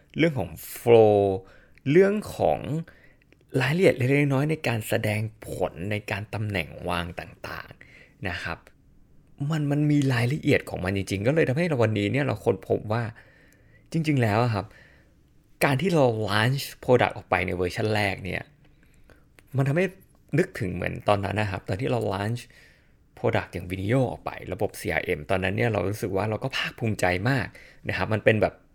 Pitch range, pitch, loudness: 100-140 Hz, 115 Hz, -25 LUFS